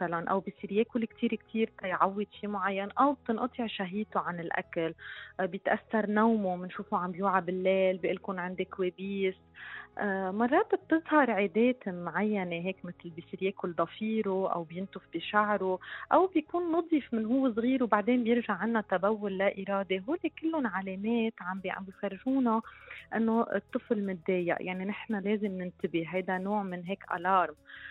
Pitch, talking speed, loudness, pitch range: 200 Hz, 135 wpm, -31 LUFS, 185-230 Hz